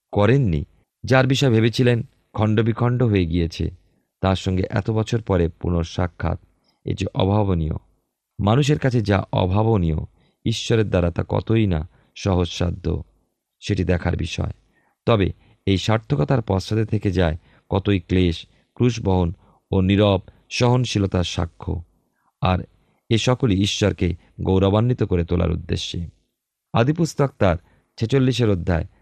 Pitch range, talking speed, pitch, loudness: 90-115 Hz, 110 wpm, 100 Hz, -21 LUFS